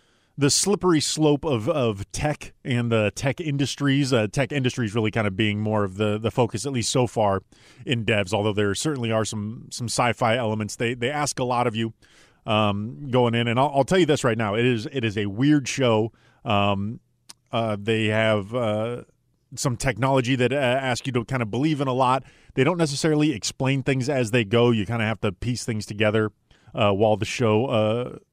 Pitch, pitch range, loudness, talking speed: 120 Hz, 110-135 Hz, -23 LUFS, 215 wpm